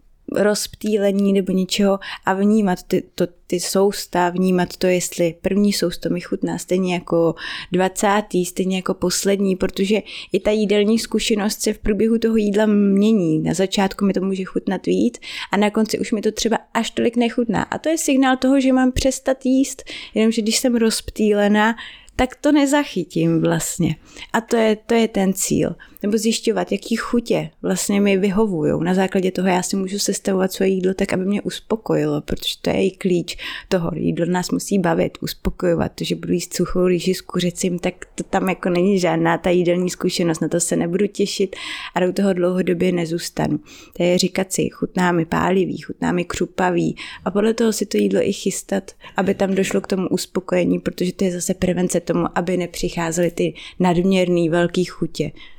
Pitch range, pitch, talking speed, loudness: 180-215 Hz, 190 Hz, 180 wpm, -20 LUFS